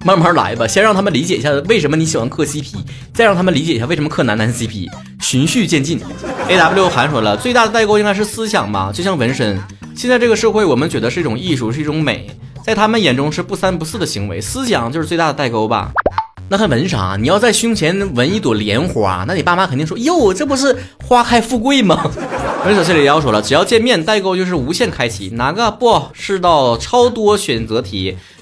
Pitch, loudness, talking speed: 160 Hz, -14 LUFS, 340 characters per minute